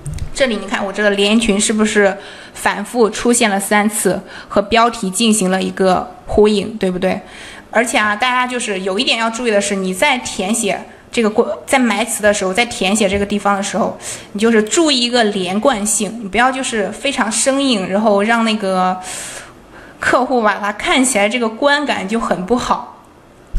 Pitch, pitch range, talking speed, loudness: 210 Hz, 200-240 Hz, 275 characters per minute, -15 LUFS